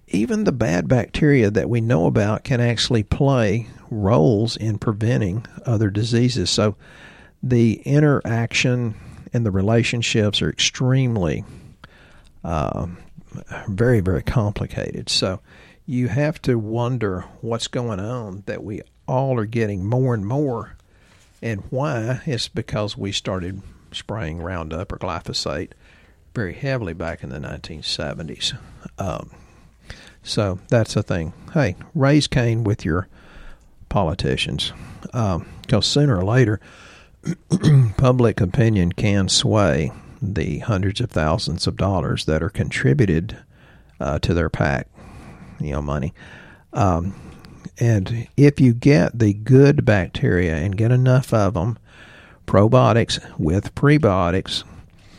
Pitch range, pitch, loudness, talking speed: 95-125 Hz, 115 Hz, -20 LUFS, 120 wpm